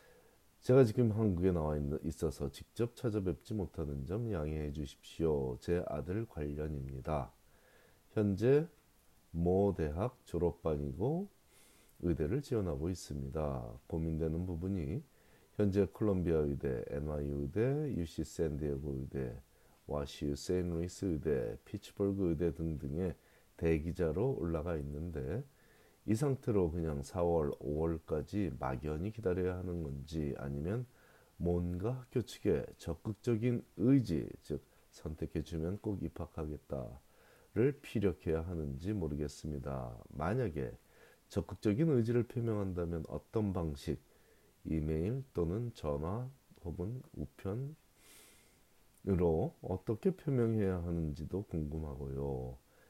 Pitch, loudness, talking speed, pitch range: 85 Hz, -37 LUFS, 255 characters per minute, 75-105 Hz